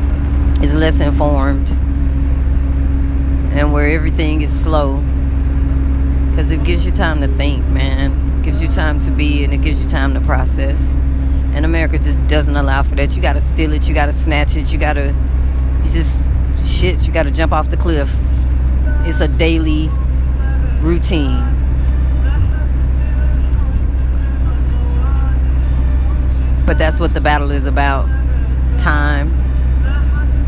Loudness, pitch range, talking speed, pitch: -15 LUFS, 65-70 Hz, 140 wpm, 65 Hz